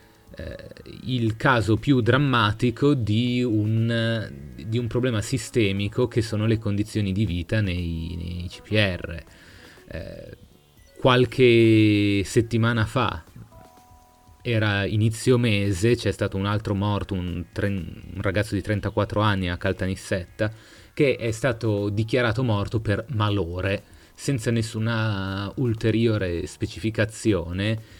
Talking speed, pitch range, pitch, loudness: 110 wpm, 95-115 Hz, 105 Hz, -23 LUFS